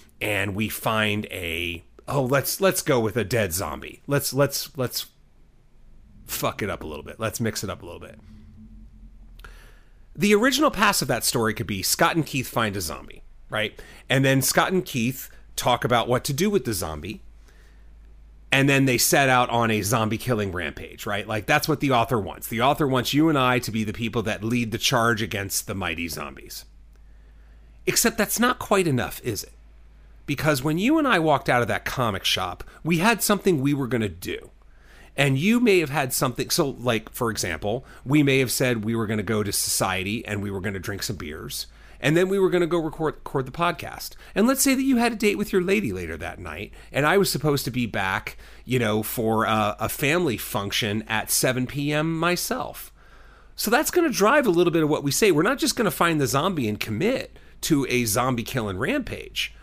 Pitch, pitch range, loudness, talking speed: 120 Hz, 105-155 Hz, -23 LUFS, 220 wpm